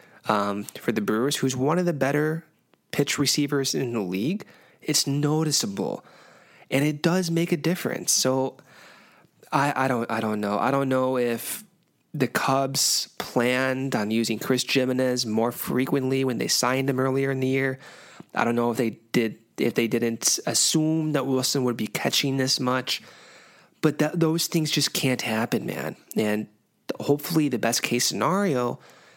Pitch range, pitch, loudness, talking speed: 120-150 Hz, 130 Hz, -24 LUFS, 165 wpm